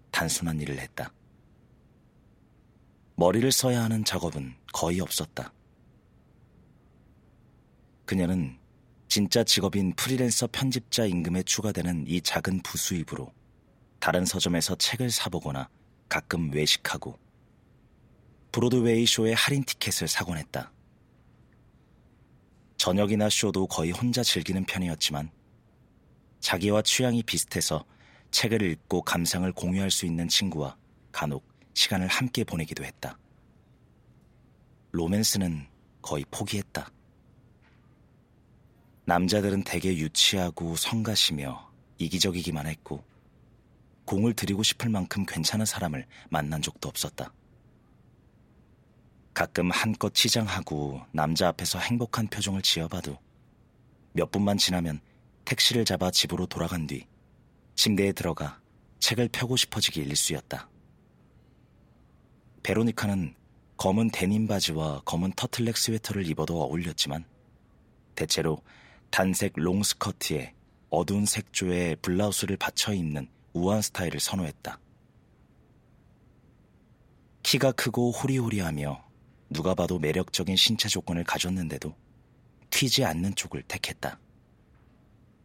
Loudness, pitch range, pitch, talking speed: -27 LUFS, 85-110 Hz, 95 Hz, 250 characters per minute